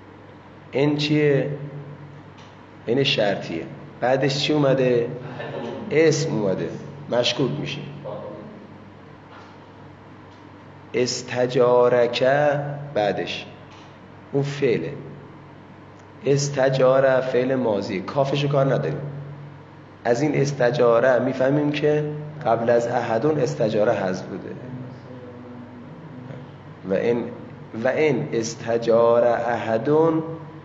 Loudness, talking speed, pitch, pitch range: -21 LUFS, 75 wpm, 130 Hz, 120-145 Hz